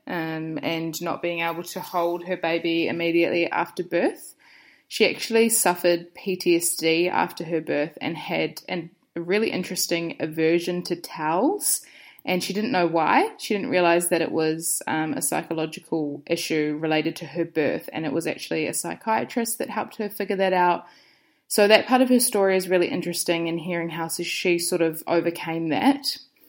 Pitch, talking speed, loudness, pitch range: 175 Hz, 170 wpm, -24 LUFS, 165-195 Hz